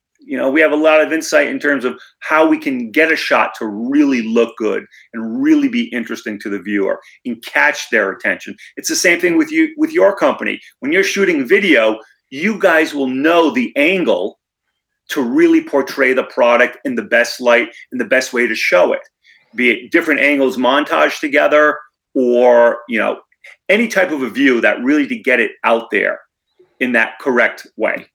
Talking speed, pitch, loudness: 195 wpm, 160 Hz, -14 LUFS